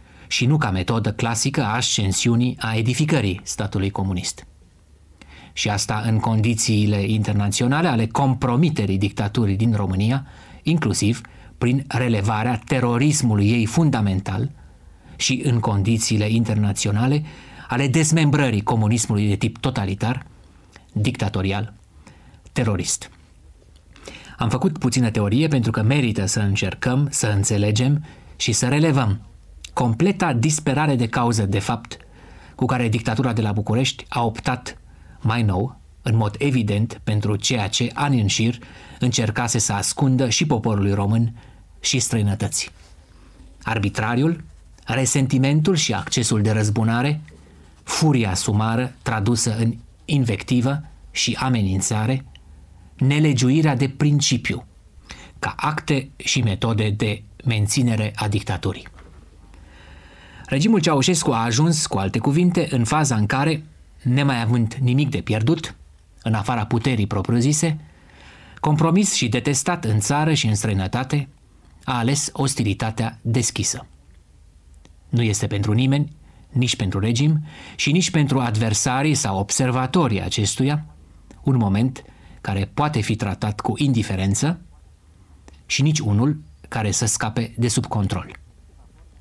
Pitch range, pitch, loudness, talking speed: 100-130 Hz, 115 Hz, -21 LUFS, 115 wpm